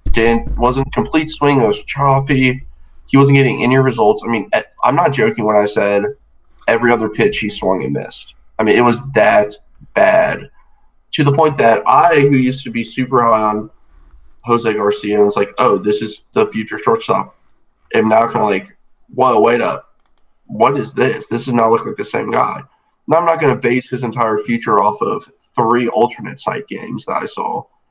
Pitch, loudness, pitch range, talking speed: 120 Hz, -14 LUFS, 105-140 Hz, 200 wpm